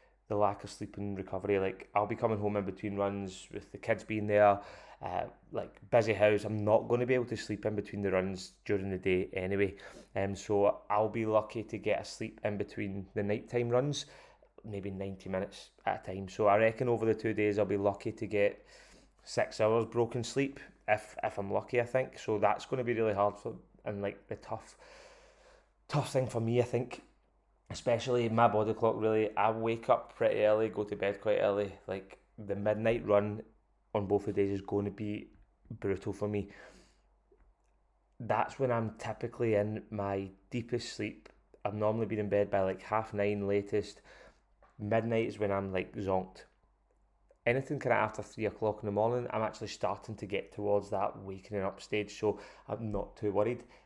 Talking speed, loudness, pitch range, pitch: 195 wpm, -33 LUFS, 100-115 Hz, 105 Hz